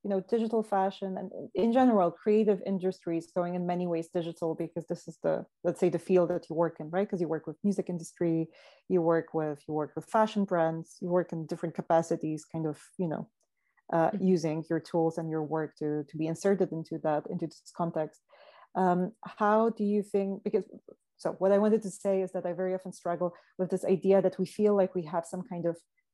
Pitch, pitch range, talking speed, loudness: 180 Hz, 165-195 Hz, 220 wpm, -30 LUFS